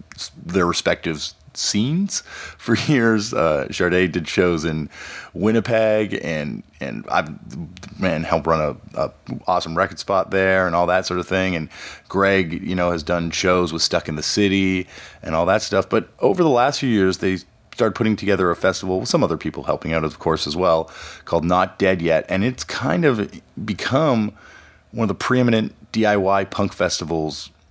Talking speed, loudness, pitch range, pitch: 180 wpm, -20 LUFS, 85-105 Hz, 95 Hz